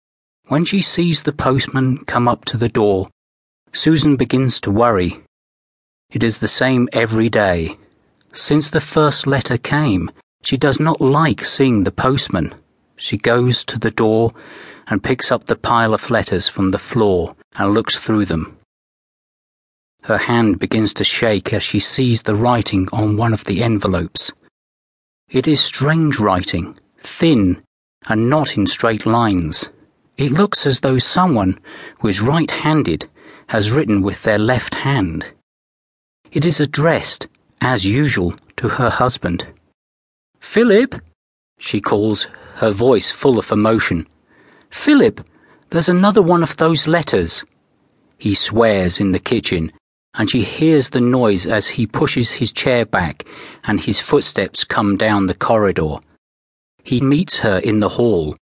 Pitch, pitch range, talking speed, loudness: 115 Hz, 100-140 Hz, 145 wpm, -16 LUFS